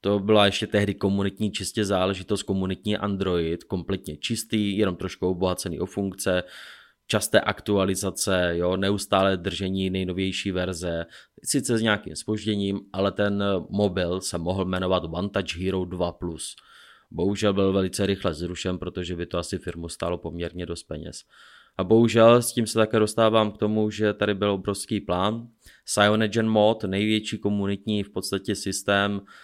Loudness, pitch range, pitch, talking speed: -25 LUFS, 90-105 Hz, 100 Hz, 145 wpm